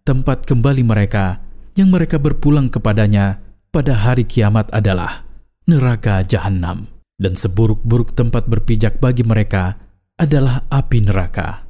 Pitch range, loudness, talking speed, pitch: 100-130 Hz, -16 LUFS, 115 wpm, 110 Hz